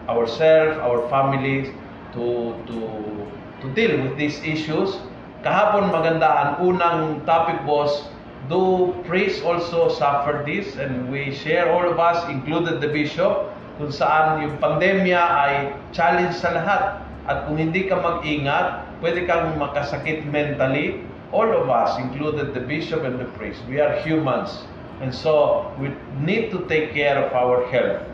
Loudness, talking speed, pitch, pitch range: -21 LUFS, 145 wpm, 150 Hz, 135-170 Hz